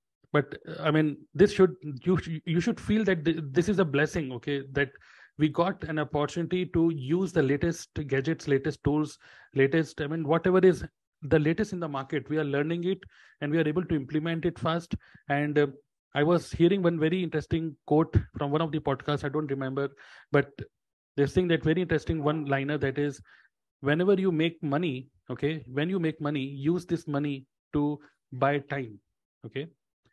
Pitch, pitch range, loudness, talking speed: 155 Hz, 140-170 Hz, -28 LUFS, 185 wpm